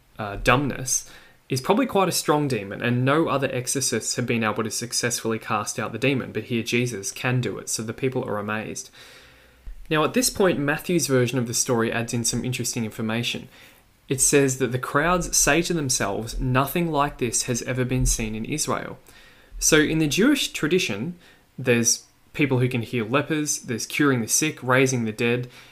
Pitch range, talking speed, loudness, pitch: 120-145 Hz, 190 wpm, -23 LUFS, 125 Hz